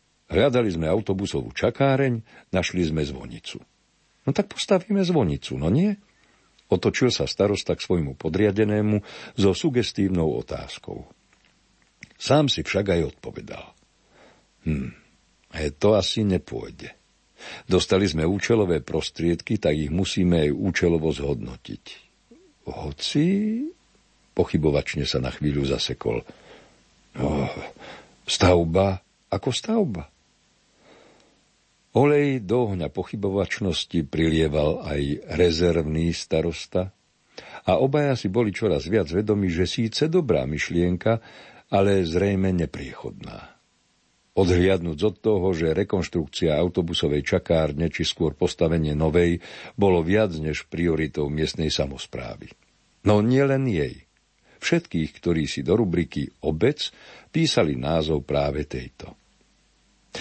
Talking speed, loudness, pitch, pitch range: 105 wpm, -23 LUFS, 90 Hz, 80-105 Hz